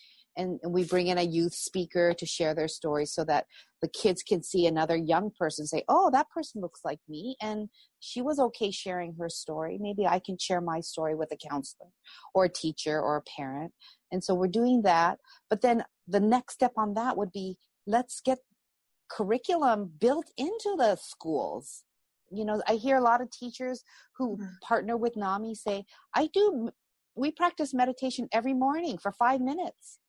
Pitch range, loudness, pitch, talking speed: 170-250 Hz, -29 LUFS, 205 Hz, 190 wpm